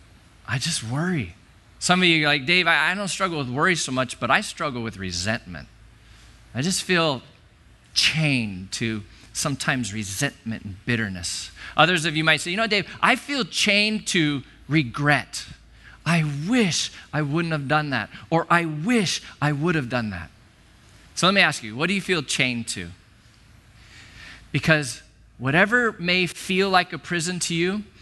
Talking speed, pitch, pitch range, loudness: 165 wpm, 145 Hz, 110-175 Hz, -22 LUFS